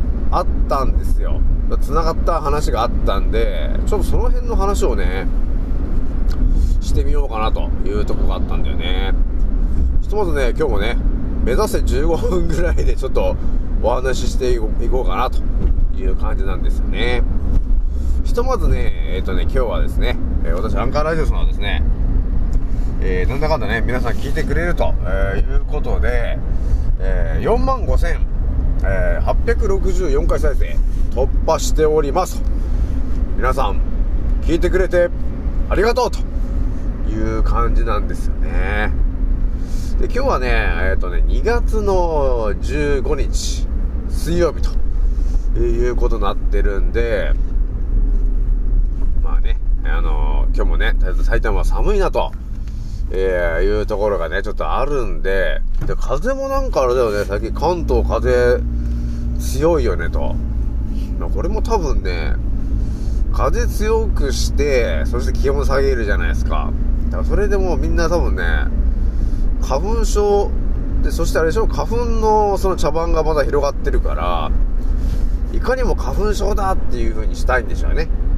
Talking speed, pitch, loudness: 270 characters per minute, 85 Hz, -20 LUFS